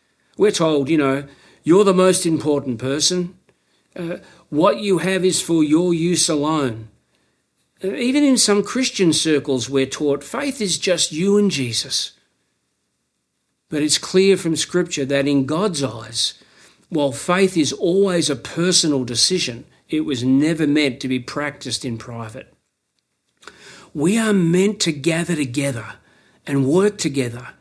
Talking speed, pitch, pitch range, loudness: 145 wpm, 155 Hz, 135-180 Hz, -18 LUFS